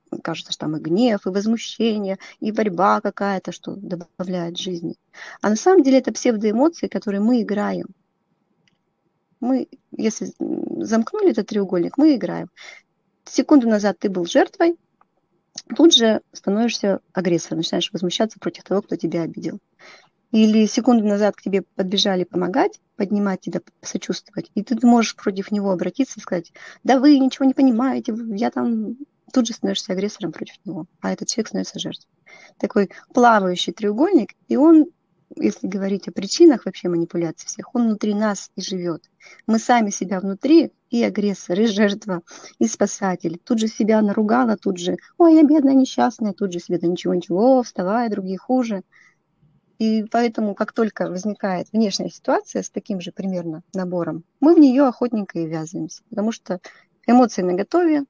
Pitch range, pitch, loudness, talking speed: 185-245 Hz, 205 Hz, -20 LUFS, 155 wpm